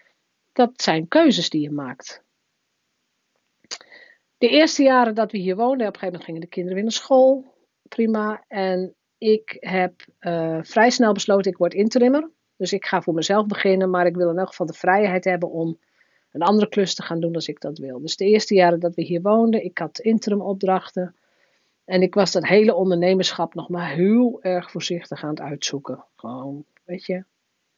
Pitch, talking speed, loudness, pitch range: 185 Hz, 190 wpm, -20 LUFS, 175-215 Hz